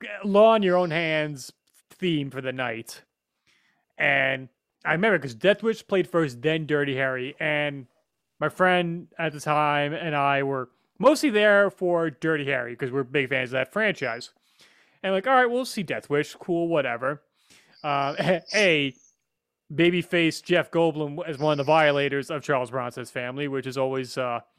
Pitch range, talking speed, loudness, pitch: 135-175 Hz, 175 wpm, -24 LUFS, 150 Hz